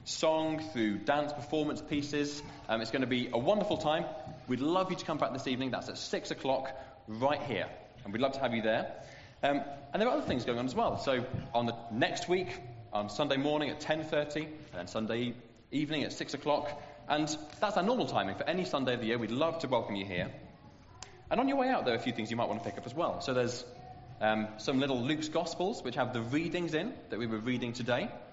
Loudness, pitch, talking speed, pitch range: -34 LUFS, 140 Hz, 240 wpm, 120-155 Hz